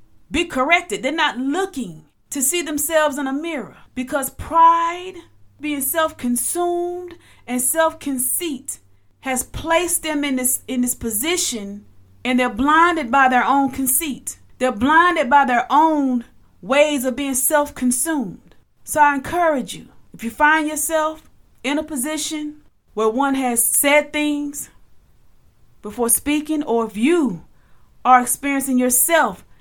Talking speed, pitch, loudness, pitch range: 130 wpm, 285 Hz, -18 LUFS, 255-315 Hz